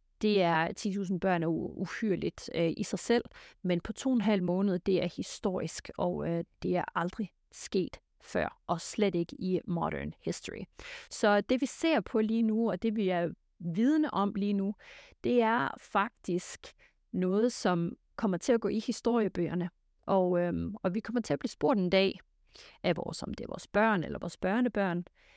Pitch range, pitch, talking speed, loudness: 180-225 Hz, 200 Hz, 190 wpm, -31 LUFS